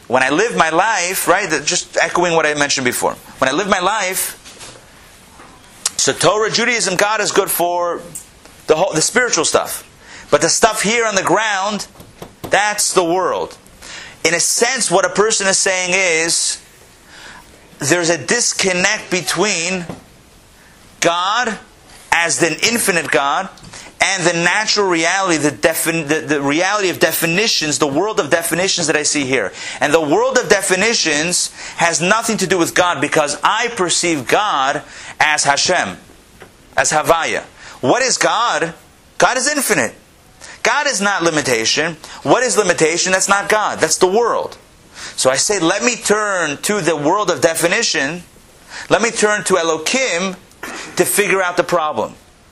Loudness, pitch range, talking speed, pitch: -15 LUFS, 165-210 Hz, 155 wpm, 180 Hz